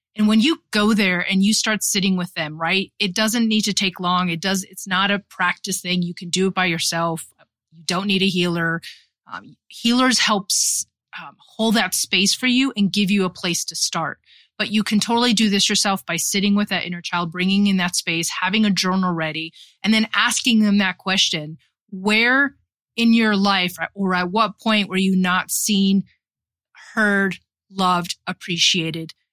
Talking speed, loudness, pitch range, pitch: 190 wpm, -19 LUFS, 180-210 Hz, 195 Hz